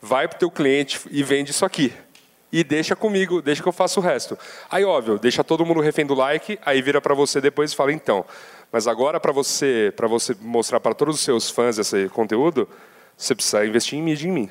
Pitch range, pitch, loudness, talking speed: 130-165 Hz, 145 Hz, -21 LUFS, 225 wpm